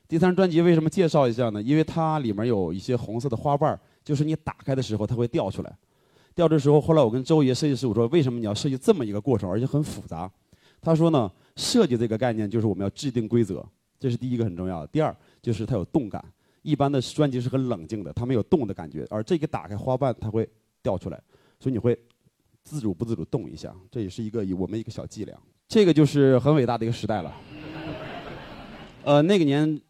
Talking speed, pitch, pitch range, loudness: 355 characters per minute, 125 Hz, 110-150 Hz, -24 LUFS